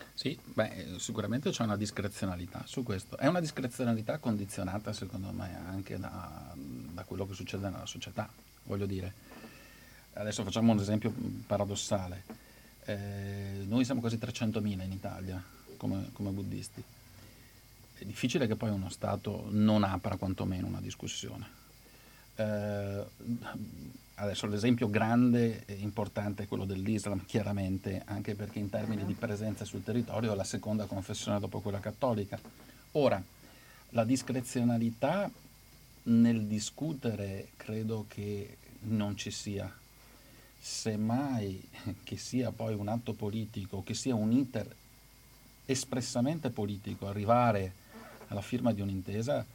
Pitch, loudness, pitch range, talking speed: 110 Hz, -34 LUFS, 100-120 Hz, 125 wpm